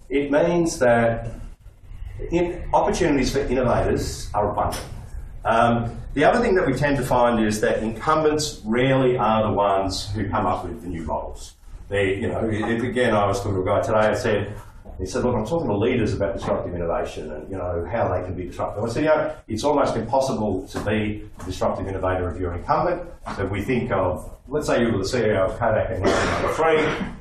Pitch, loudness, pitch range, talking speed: 105 Hz, -22 LUFS, 95-125 Hz, 210 wpm